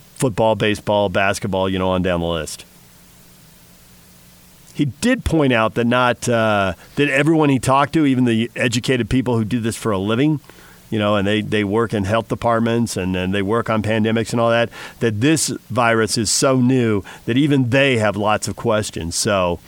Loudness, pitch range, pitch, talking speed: -18 LUFS, 100-125 Hz, 115 Hz, 190 wpm